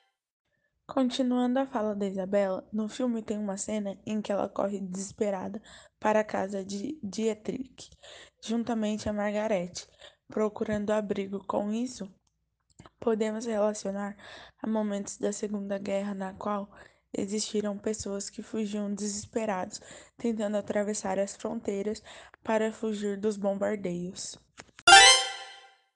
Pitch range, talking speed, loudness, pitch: 200-220 Hz, 115 wpm, -28 LUFS, 210 Hz